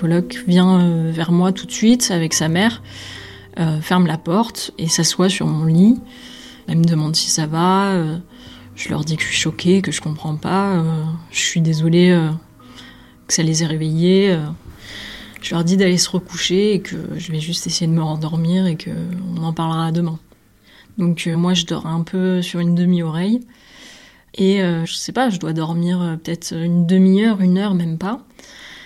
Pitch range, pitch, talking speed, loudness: 160-185 Hz, 170 Hz, 195 wpm, -17 LUFS